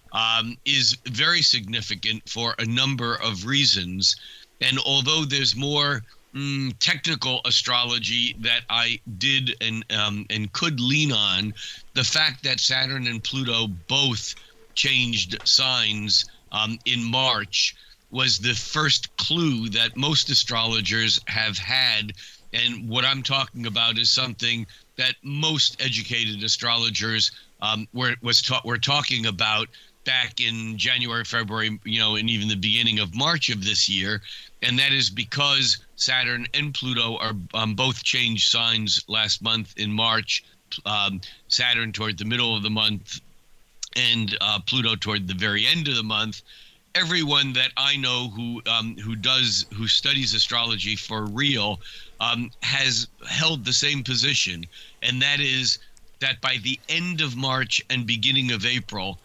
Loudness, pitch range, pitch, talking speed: -21 LUFS, 110-130 Hz, 120 Hz, 145 wpm